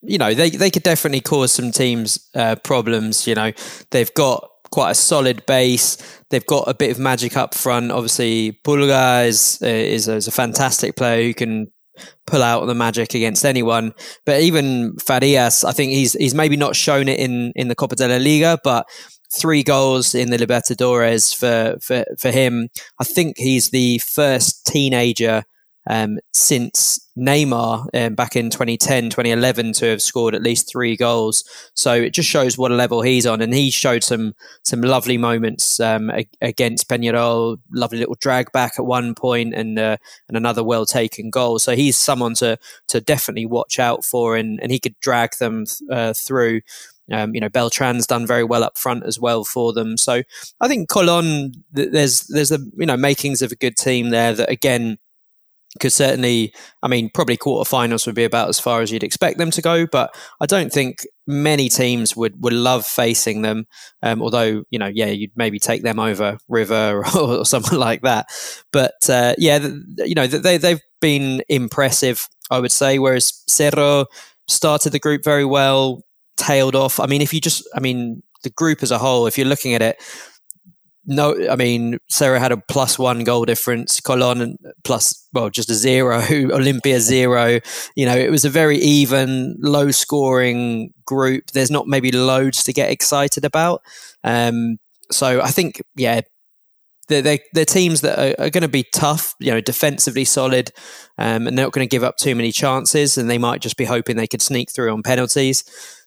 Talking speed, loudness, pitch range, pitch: 190 wpm, -17 LUFS, 115-140 Hz, 125 Hz